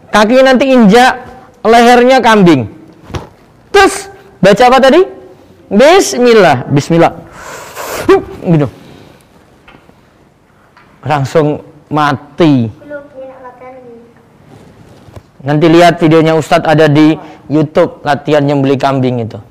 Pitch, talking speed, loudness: 170 Hz, 80 wpm, -8 LUFS